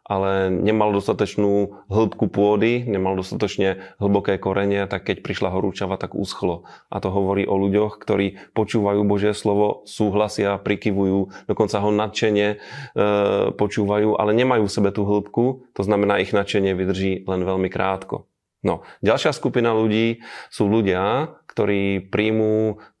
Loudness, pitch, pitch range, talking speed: -21 LUFS, 105 Hz, 100-105 Hz, 140 wpm